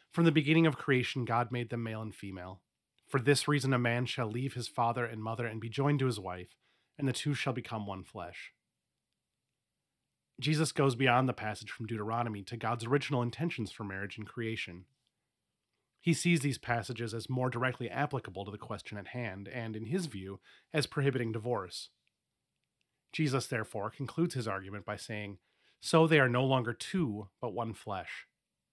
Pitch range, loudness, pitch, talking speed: 110-135 Hz, -33 LUFS, 120 Hz, 180 wpm